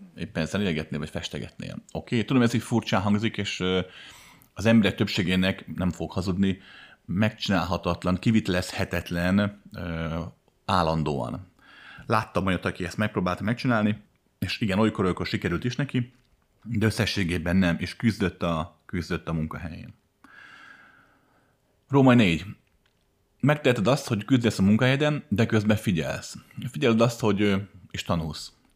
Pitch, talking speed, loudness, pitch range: 100 Hz, 125 wpm, -26 LUFS, 90-115 Hz